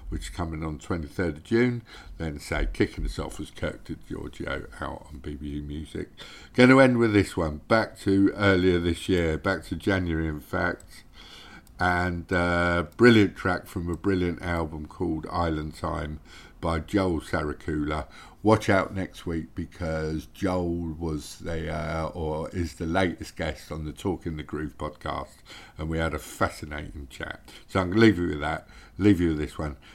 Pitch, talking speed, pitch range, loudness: 85 Hz, 180 wpm, 75-95 Hz, -27 LUFS